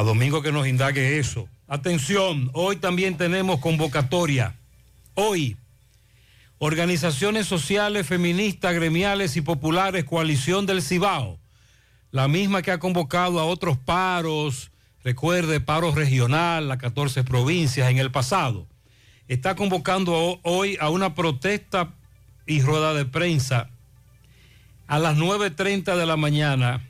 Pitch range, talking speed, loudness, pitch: 125-180 Hz, 120 wpm, -23 LUFS, 155 Hz